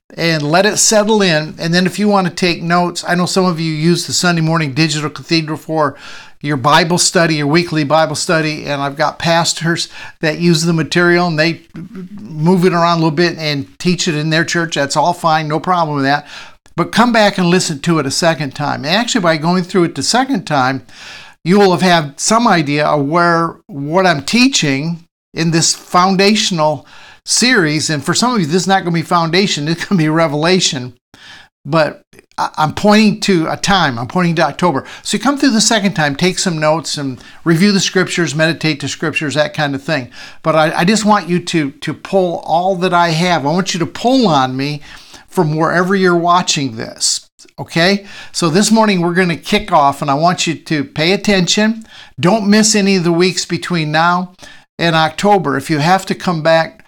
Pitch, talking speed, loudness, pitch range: 170 Hz, 210 wpm, -13 LUFS, 155-185 Hz